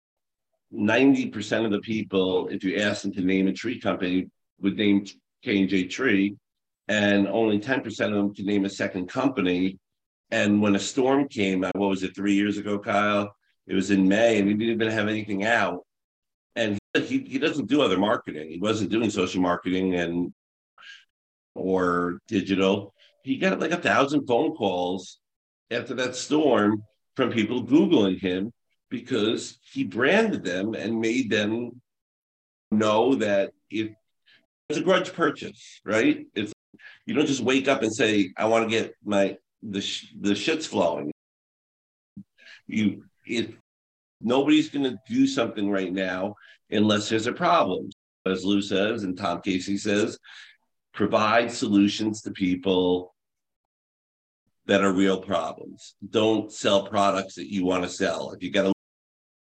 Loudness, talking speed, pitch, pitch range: -25 LUFS, 155 wpm, 100 Hz, 95-110 Hz